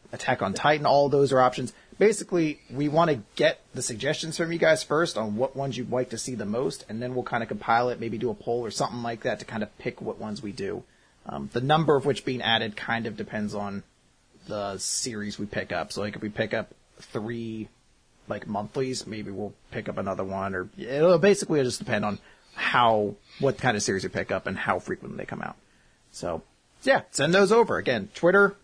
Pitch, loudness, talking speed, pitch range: 120 Hz, -26 LUFS, 225 wpm, 105-145 Hz